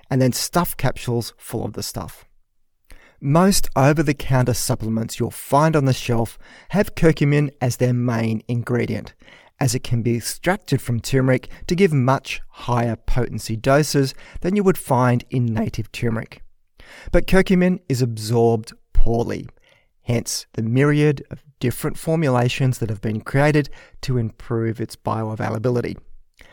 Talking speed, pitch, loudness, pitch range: 140 wpm, 125 Hz, -21 LUFS, 115-145 Hz